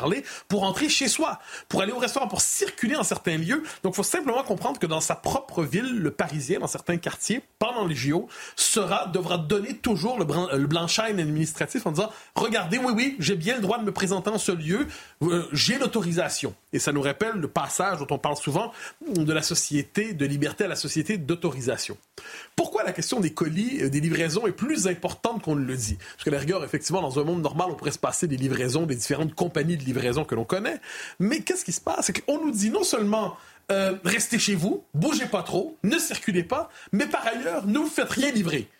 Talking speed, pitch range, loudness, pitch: 220 wpm, 160-225 Hz, -26 LUFS, 185 Hz